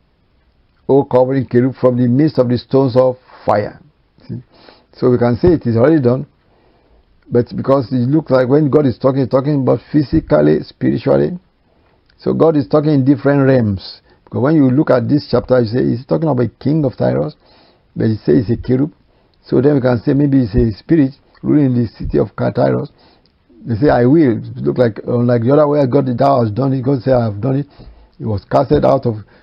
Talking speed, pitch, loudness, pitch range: 210 wpm, 130 Hz, -14 LUFS, 120-140 Hz